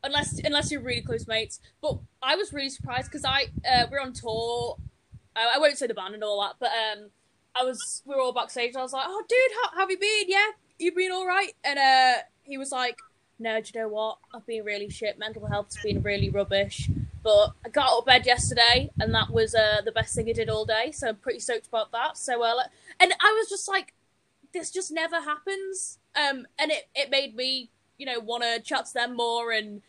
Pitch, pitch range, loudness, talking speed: 255 Hz, 225-330 Hz, -26 LUFS, 240 wpm